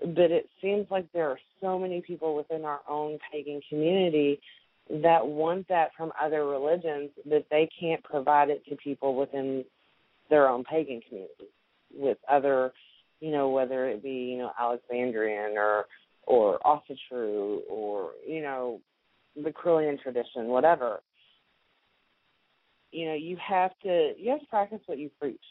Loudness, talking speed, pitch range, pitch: -29 LUFS, 150 wpm, 135-180 Hz, 150 Hz